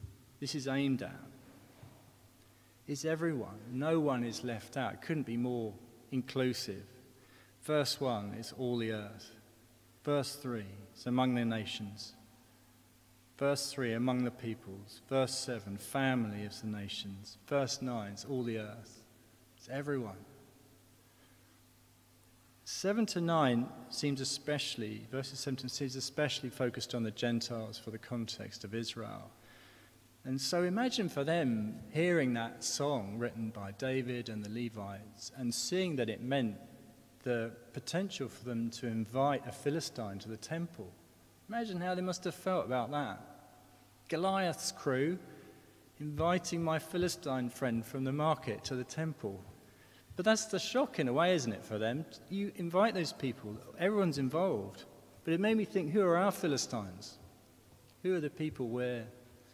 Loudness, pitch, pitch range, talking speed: -36 LUFS, 125 Hz, 110-145 Hz, 145 wpm